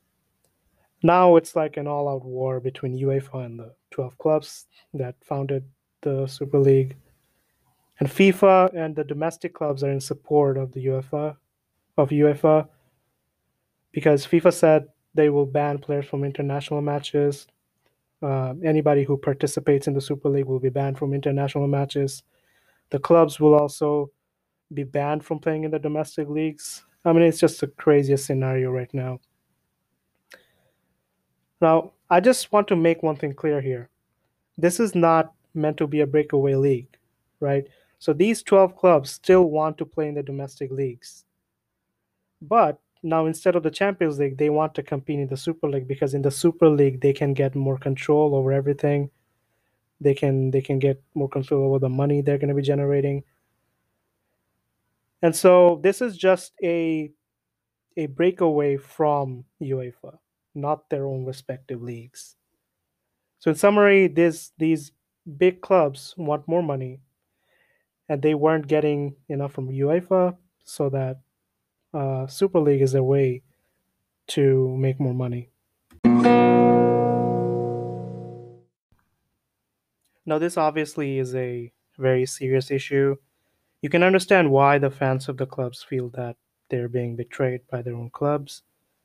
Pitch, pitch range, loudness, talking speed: 145 Hz, 135-155 Hz, -22 LUFS, 150 wpm